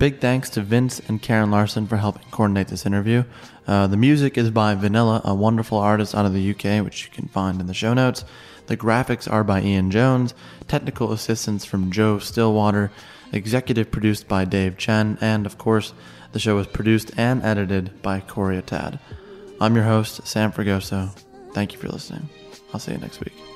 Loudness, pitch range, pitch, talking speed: -21 LUFS, 100-115 Hz, 110 Hz, 190 wpm